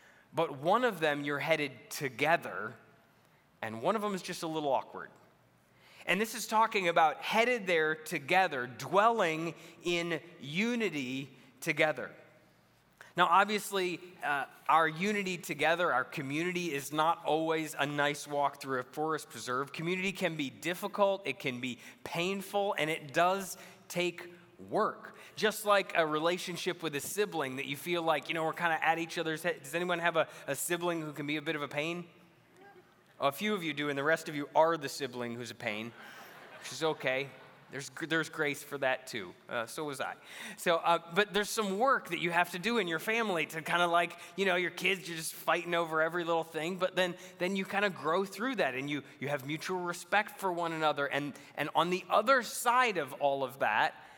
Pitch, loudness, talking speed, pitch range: 165 Hz, -32 LUFS, 200 wpm, 145-185 Hz